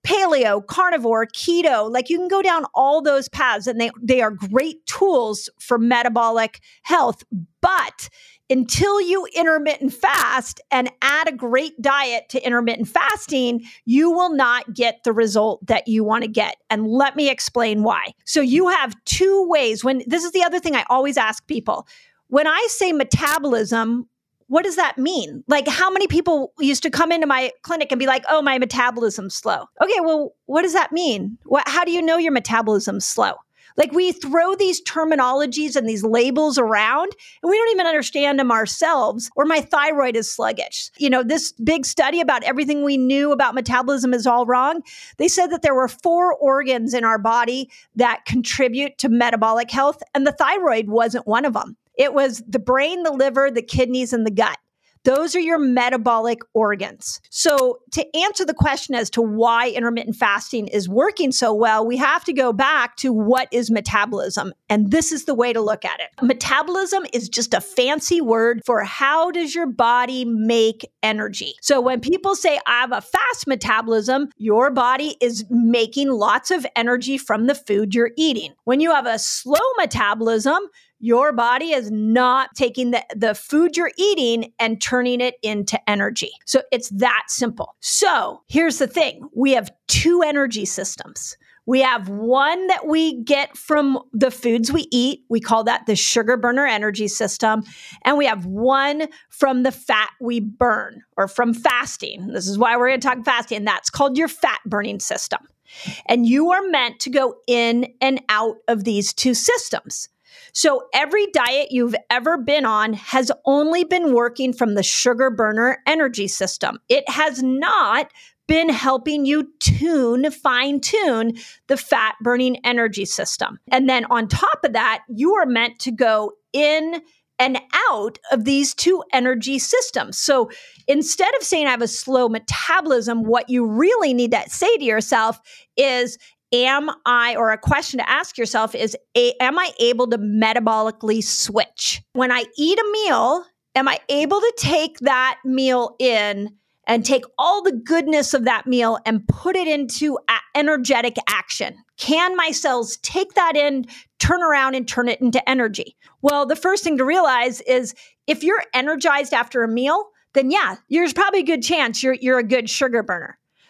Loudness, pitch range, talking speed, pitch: -19 LUFS, 235-310 Hz, 175 wpm, 260 Hz